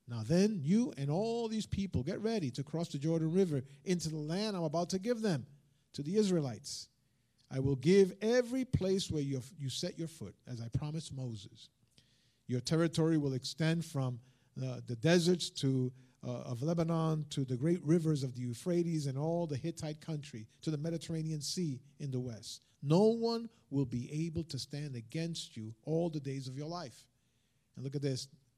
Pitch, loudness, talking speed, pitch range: 150 Hz, -35 LUFS, 185 wpm, 130-170 Hz